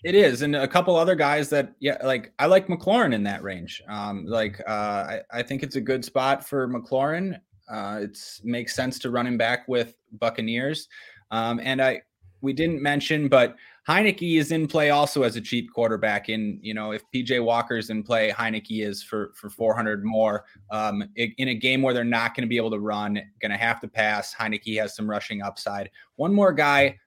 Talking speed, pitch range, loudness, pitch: 210 wpm, 105-135 Hz, -24 LUFS, 115 Hz